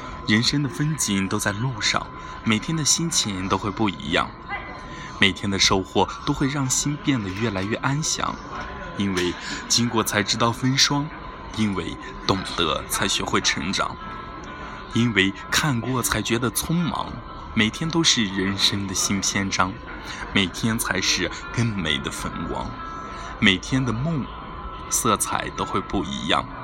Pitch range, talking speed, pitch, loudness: 100-140 Hz, 205 characters per minute, 115 Hz, -22 LUFS